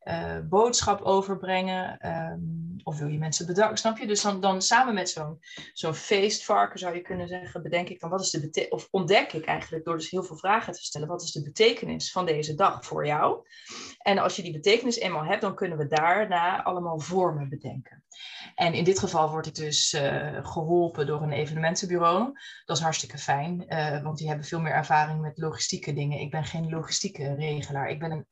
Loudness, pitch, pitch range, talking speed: -27 LUFS, 165 Hz, 155-190 Hz, 210 wpm